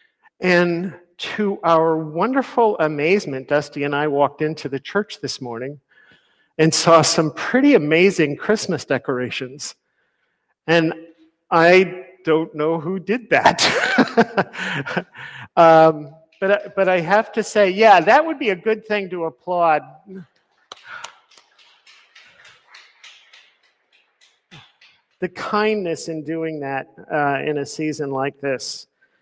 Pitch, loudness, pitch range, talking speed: 165 Hz, -18 LUFS, 150-195 Hz, 115 wpm